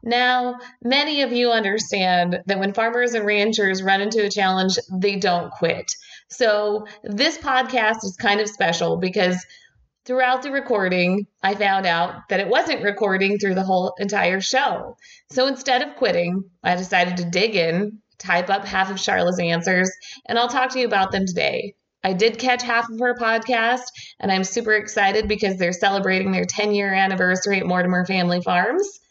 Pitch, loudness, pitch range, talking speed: 205 Hz, -20 LUFS, 185-235 Hz, 175 wpm